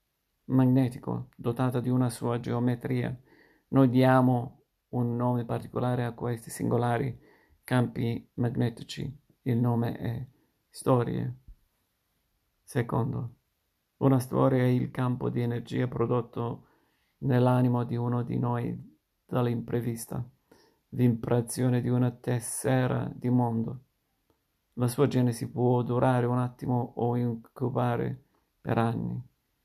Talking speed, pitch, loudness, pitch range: 105 wpm, 120 Hz, -29 LUFS, 120-125 Hz